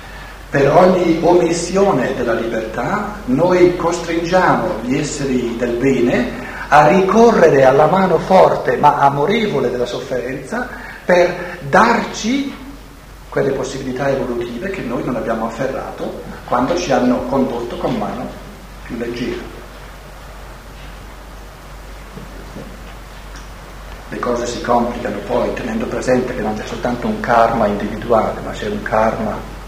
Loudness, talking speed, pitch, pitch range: -16 LUFS, 115 wpm, 165 Hz, 120-185 Hz